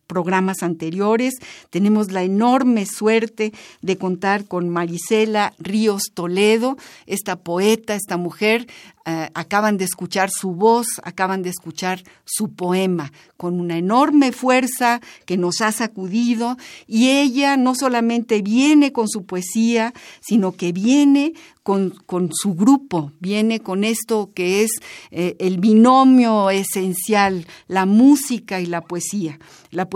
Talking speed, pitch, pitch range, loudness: 130 wpm, 205 Hz, 180-230 Hz, -18 LUFS